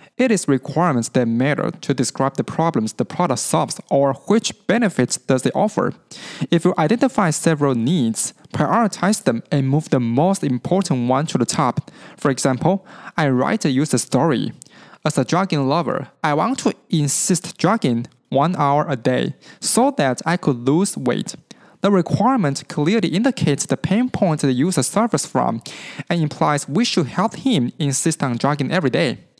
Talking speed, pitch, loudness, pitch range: 165 wpm, 160 Hz, -19 LUFS, 140-195 Hz